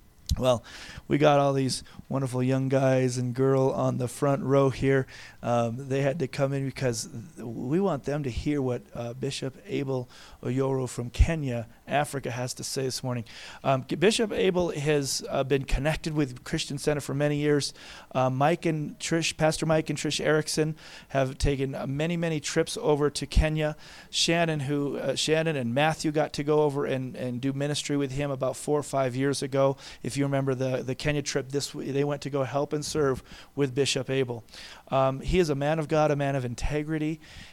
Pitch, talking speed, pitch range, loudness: 140 Hz, 195 wpm, 130-150 Hz, -27 LUFS